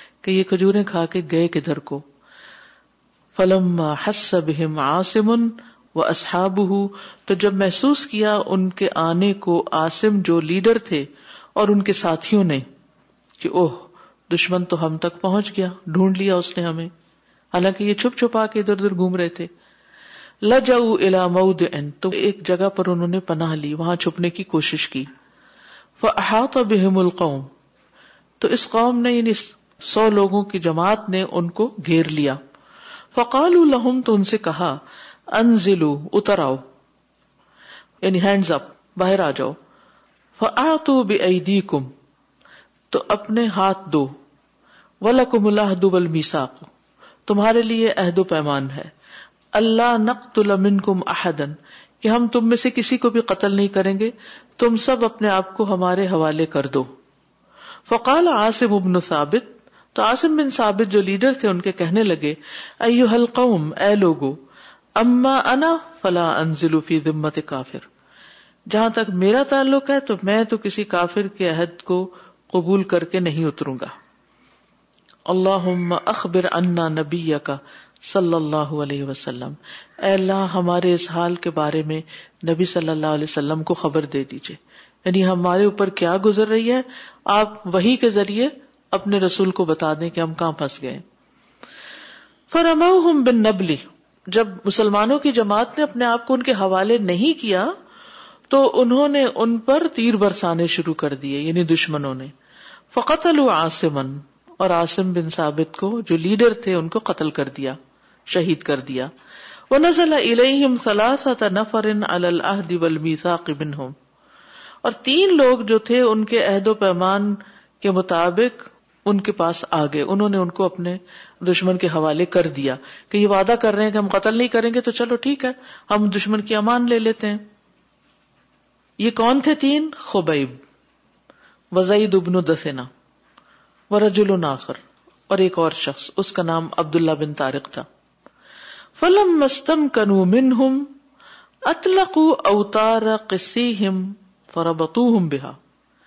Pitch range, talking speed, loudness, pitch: 165-225 Hz, 145 wpm, -19 LUFS, 195 Hz